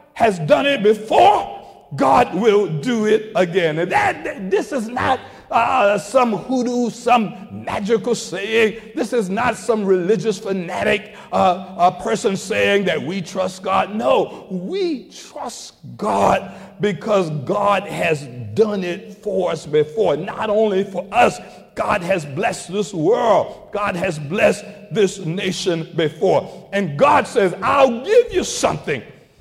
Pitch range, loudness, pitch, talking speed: 185-225 Hz, -18 LUFS, 205 Hz, 140 wpm